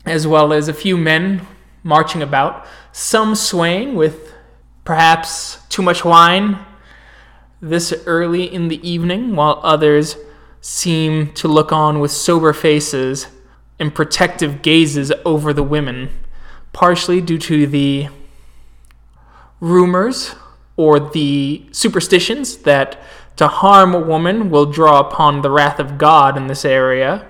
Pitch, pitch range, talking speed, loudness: 155 Hz, 145-175 Hz, 130 wpm, -14 LUFS